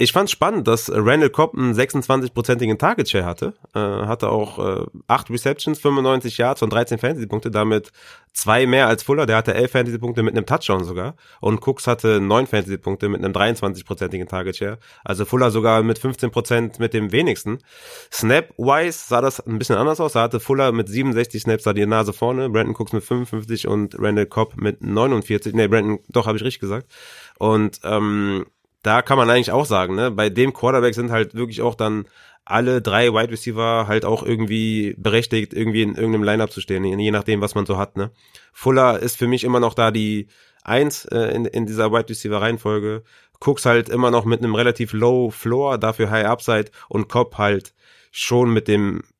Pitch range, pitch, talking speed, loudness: 105-125 Hz, 115 Hz, 190 wpm, -19 LUFS